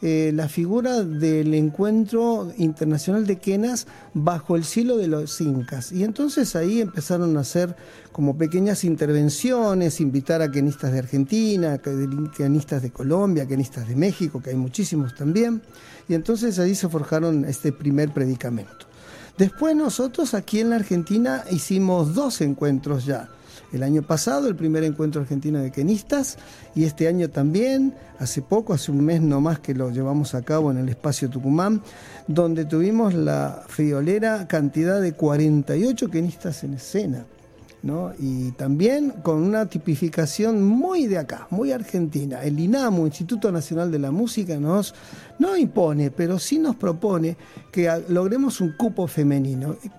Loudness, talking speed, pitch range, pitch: -22 LUFS, 150 wpm, 145-205 Hz, 165 Hz